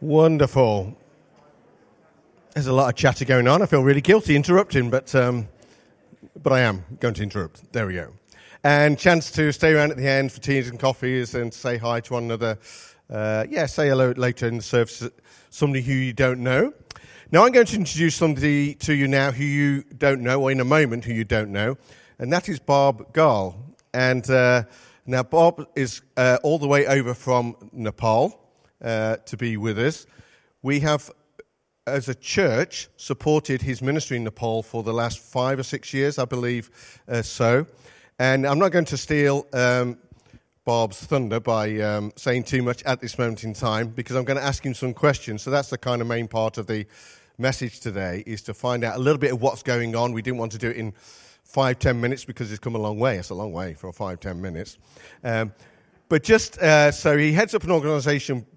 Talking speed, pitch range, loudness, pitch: 205 wpm, 115-145 Hz, -22 LUFS, 130 Hz